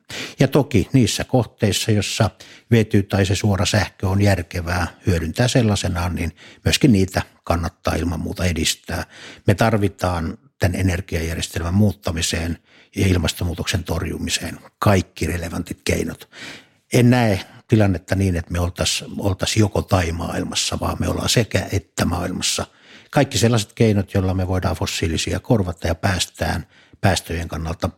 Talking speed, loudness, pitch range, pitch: 130 wpm, -20 LUFS, 85-105 Hz, 95 Hz